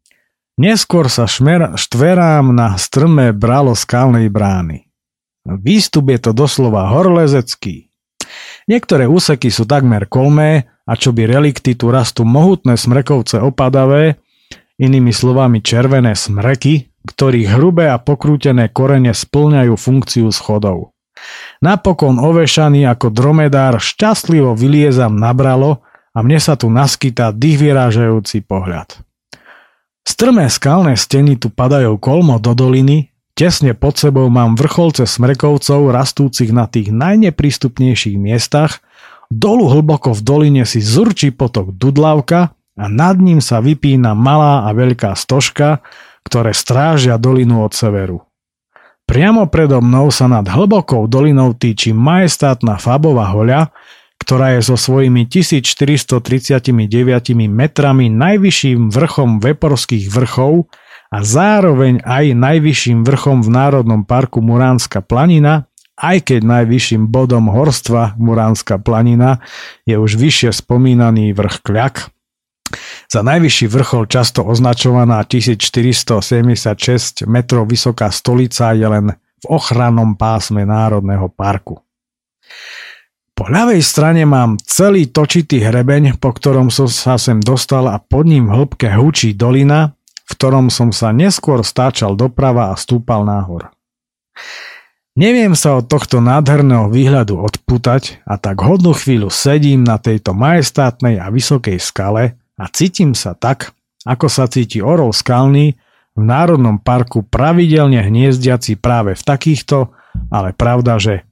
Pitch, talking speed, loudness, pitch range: 125 Hz, 120 wpm, -11 LUFS, 115-145 Hz